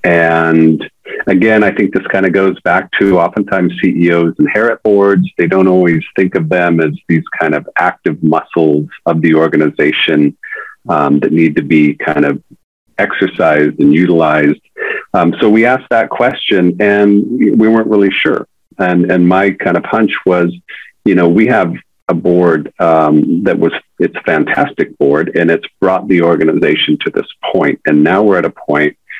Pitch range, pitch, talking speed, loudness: 80-95 Hz, 85 Hz, 175 wpm, -11 LUFS